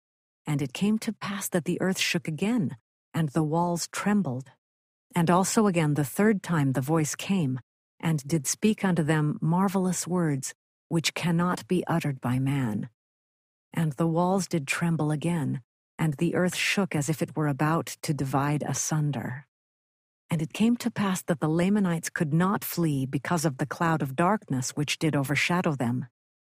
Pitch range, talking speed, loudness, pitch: 145-180 Hz, 170 wpm, -27 LUFS, 165 Hz